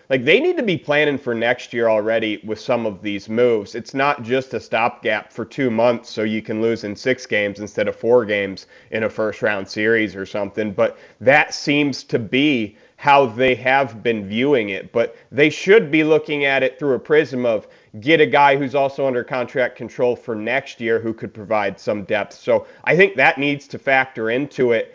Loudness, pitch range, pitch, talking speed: -19 LUFS, 110-140 Hz, 125 Hz, 210 wpm